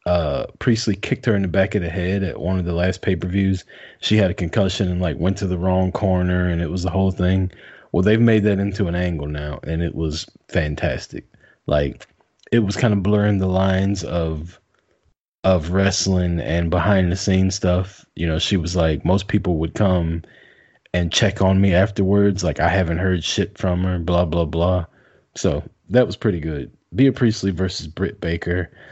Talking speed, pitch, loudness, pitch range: 200 wpm, 90 Hz, -20 LUFS, 85-100 Hz